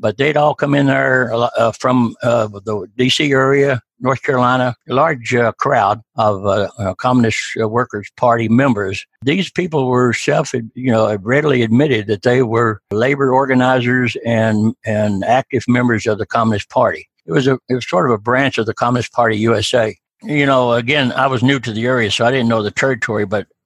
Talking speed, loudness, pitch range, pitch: 195 wpm, -15 LUFS, 110-130 Hz, 120 Hz